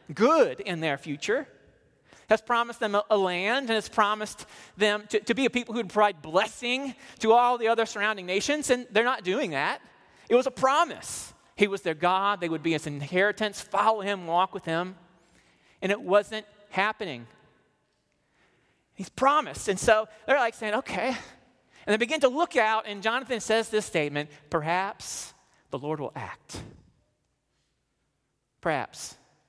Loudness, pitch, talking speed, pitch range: -26 LUFS, 210 Hz, 165 wpm, 185-235 Hz